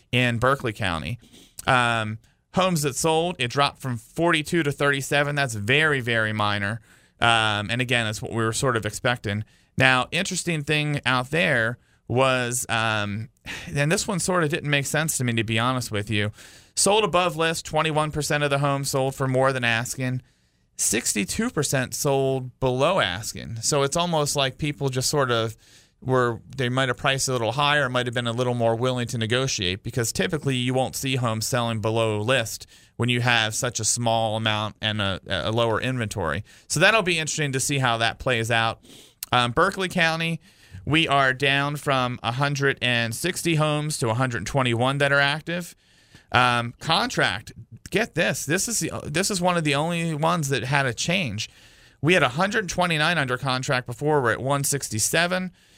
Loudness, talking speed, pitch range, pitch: -23 LUFS, 175 wpm, 115-150 Hz, 130 Hz